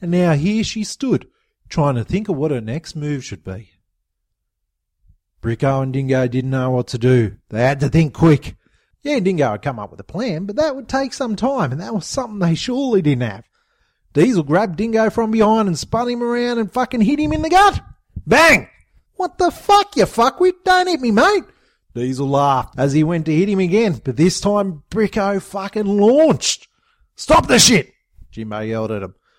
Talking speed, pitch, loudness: 200 wpm, 180 Hz, -17 LUFS